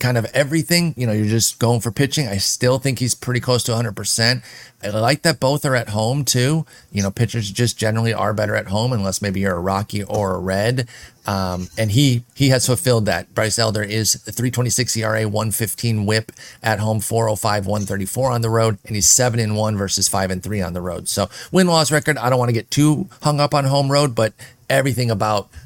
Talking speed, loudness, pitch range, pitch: 220 wpm, -18 LUFS, 105-125 Hz, 115 Hz